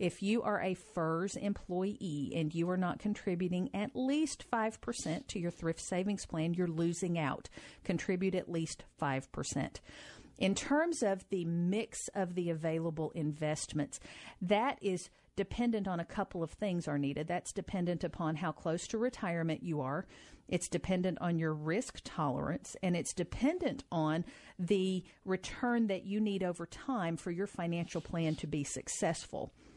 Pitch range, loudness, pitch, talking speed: 165-200 Hz, -36 LUFS, 180 Hz, 155 wpm